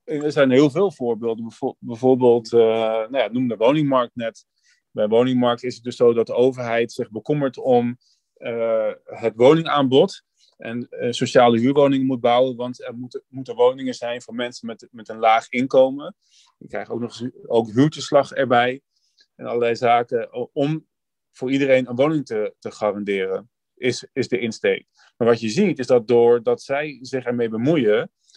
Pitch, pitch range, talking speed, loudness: 125 Hz, 115-135 Hz, 170 wpm, -20 LUFS